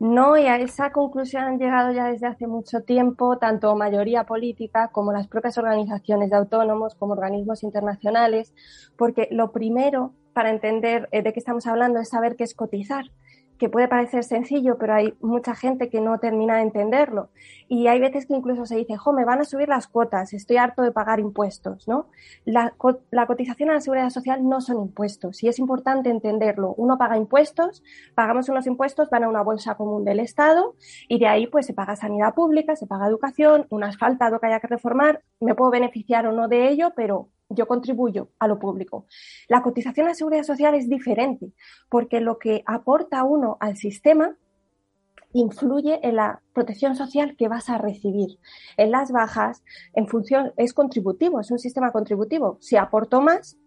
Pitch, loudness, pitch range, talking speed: 235 Hz, -22 LUFS, 220-260 Hz, 185 wpm